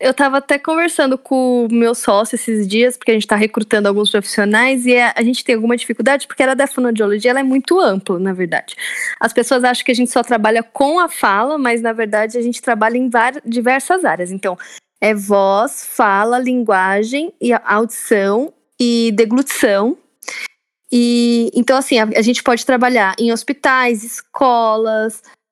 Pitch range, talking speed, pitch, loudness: 220-260 Hz, 170 wpm, 240 Hz, -15 LUFS